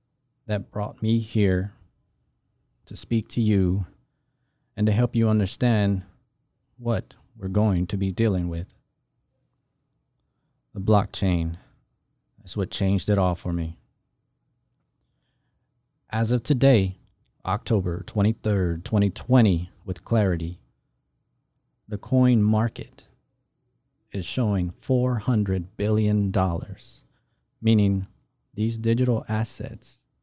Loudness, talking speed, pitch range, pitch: -24 LUFS, 95 wpm, 95-120 Hz, 105 Hz